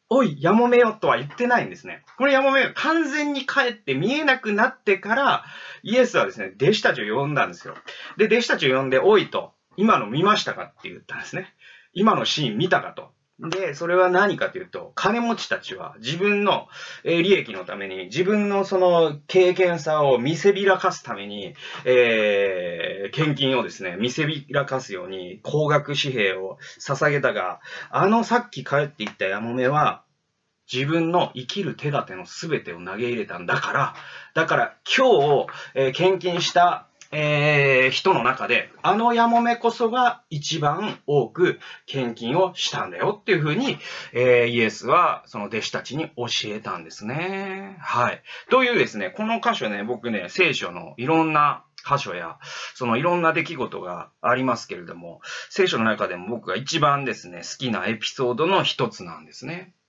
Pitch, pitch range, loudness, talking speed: 165 Hz, 130-210 Hz, -22 LUFS, 340 characters per minute